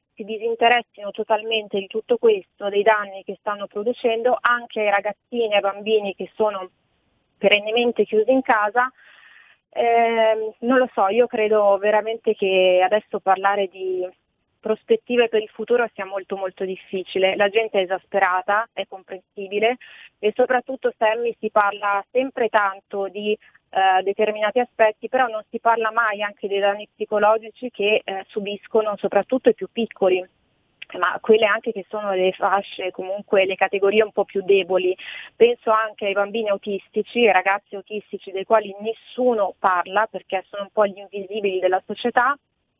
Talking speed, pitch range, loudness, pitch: 155 wpm, 195-225 Hz, -21 LUFS, 210 Hz